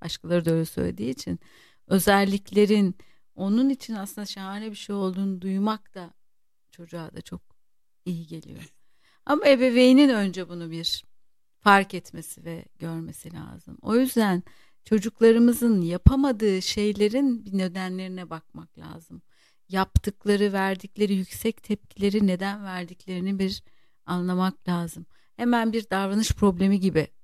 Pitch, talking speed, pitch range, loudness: 195 Hz, 115 wpm, 175-210 Hz, -24 LUFS